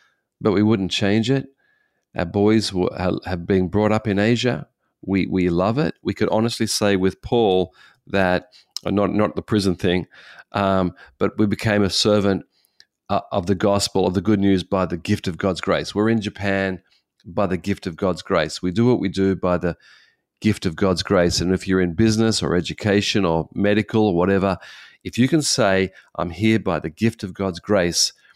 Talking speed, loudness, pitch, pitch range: 200 wpm, -20 LUFS, 100 Hz, 95-105 Hz